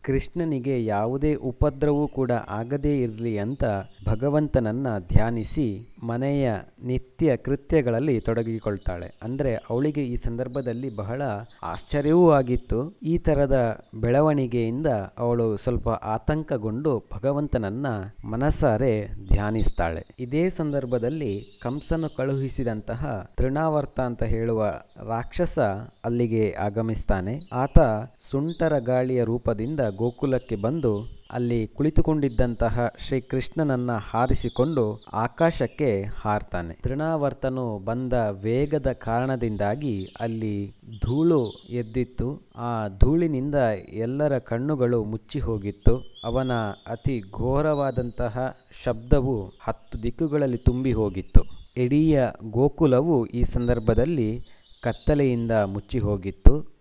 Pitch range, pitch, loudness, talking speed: 110-140 Hz, 120 Hz, -25 LUFS, 85 wpm